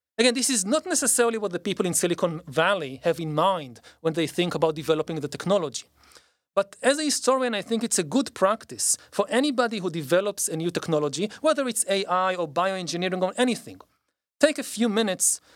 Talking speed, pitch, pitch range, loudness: 190 wpm, 195 Hz, 165-235 Hz, -24 LUFS